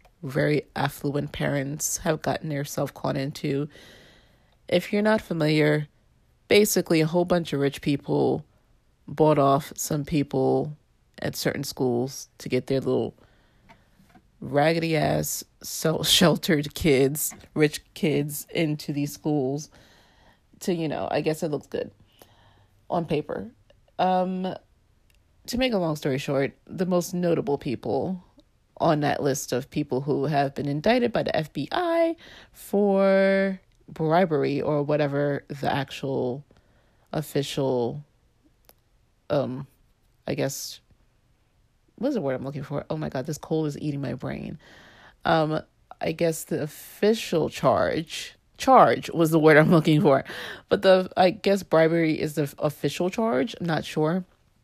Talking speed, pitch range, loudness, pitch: 135 wpm, 135-170 Hz, -25 LUFS, 150 Hz